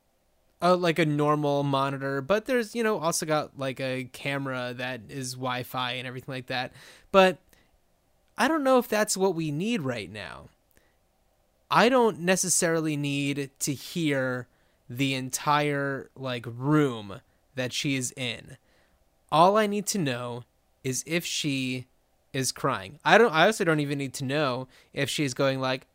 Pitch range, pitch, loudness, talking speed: 125-165 Hz, 140 Hz, -26 LUFS, 160 wpm